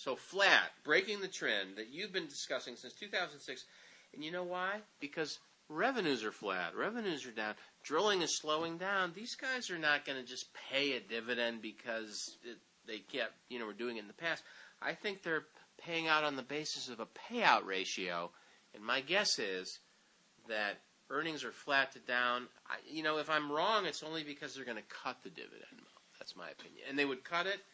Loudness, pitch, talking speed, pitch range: -37 LUFS, 145 Hz, 200 wpm, 120-170 Hz